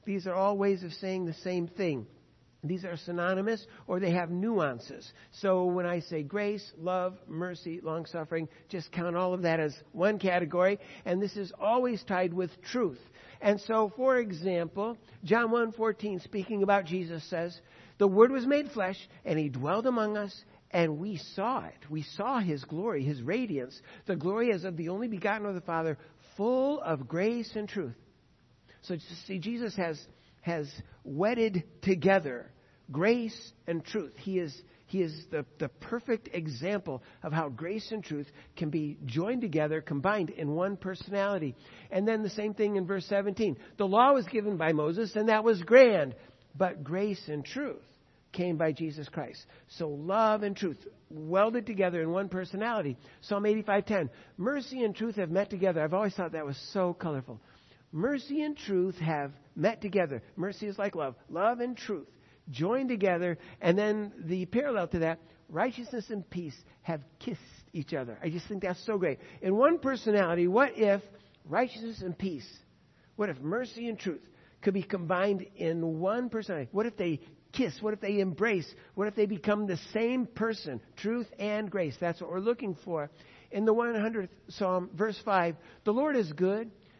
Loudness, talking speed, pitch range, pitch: -31 LUFS, 175 wpm, 165-210 Hz, 190 Hz